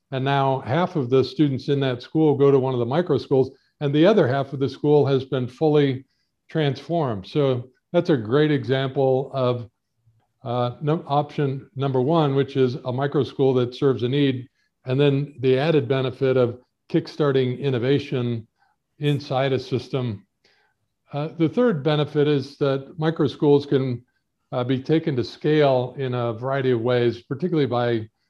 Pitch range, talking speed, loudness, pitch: 125-145 Hz, 170 wpm, -22 LUFS, 135 Hz